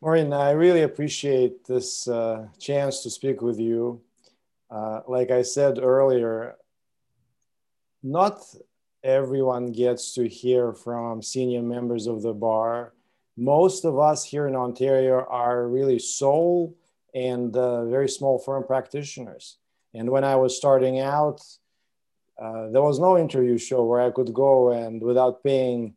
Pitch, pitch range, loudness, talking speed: 130 Hz, 120-140 Hz, -23 LUFS, 140 wpm